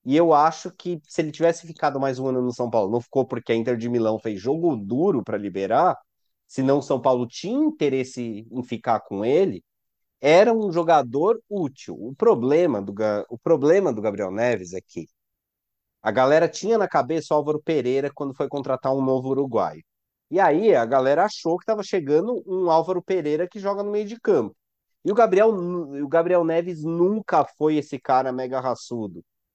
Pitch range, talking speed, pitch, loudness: 125-175 Hz, 190 wpm, 145 Hz, -22 LUFS